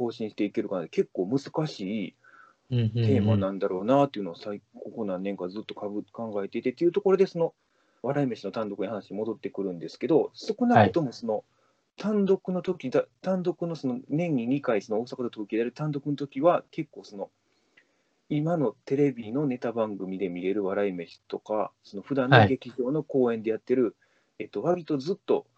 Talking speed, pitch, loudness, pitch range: 335 characters per minute, 130 Hz, -28 LUFS, 110-170 Hz